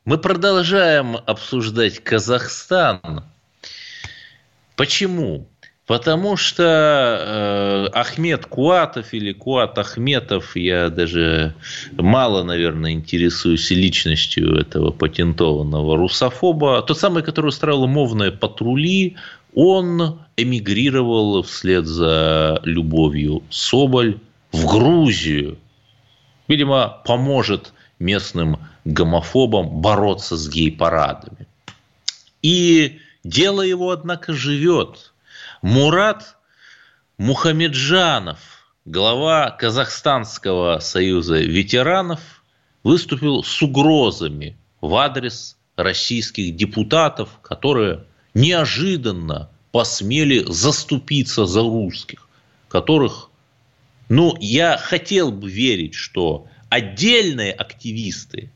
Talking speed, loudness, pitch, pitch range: 80 wpm, -17 LUFS, 120 Hz, 95-150 Hz